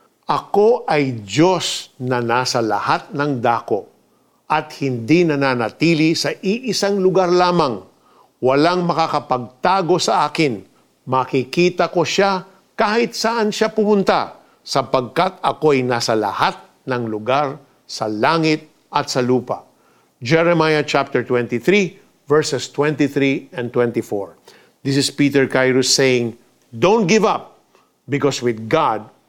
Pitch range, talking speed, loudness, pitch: 125-175 Hz, 115 wpm, -18 LUFS, 145 Hz